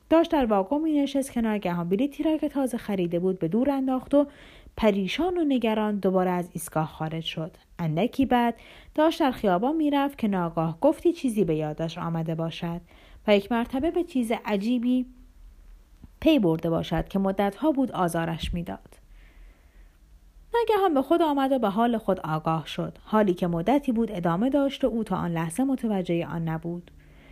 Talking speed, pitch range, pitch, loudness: 170 wpm, 165-265 Hz, 205 Hz, -26 LUFS